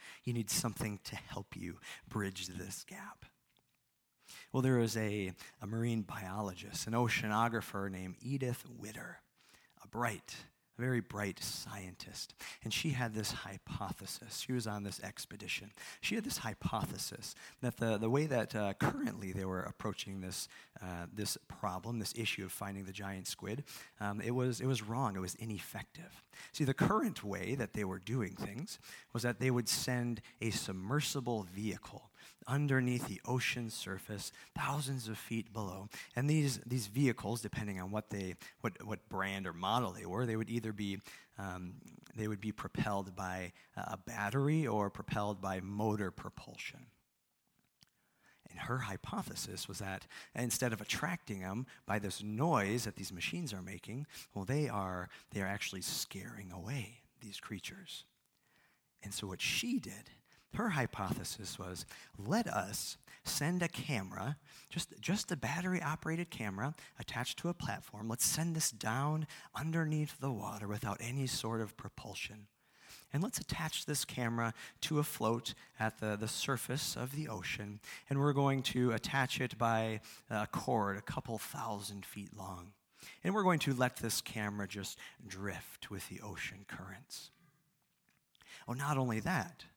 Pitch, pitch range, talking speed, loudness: 115 Hz, 100-135 Hz, 160 wpm, -39 LUFS